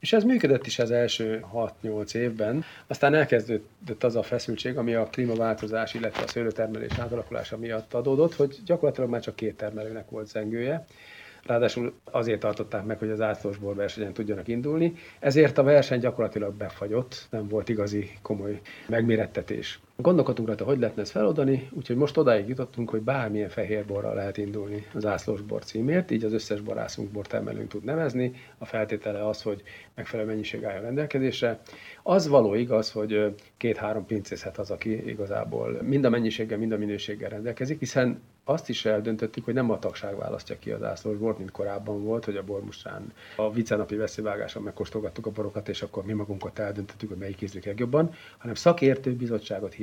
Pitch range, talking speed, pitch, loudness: 105-125 Hz, 165 wpm, 110 Hz, -28 LUFS